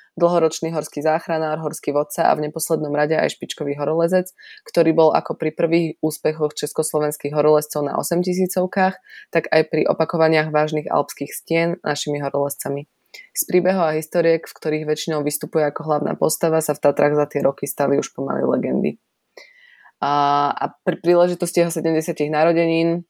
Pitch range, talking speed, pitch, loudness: 150-170 Hz, 150 wpm, 155 Hz, -20 LUFS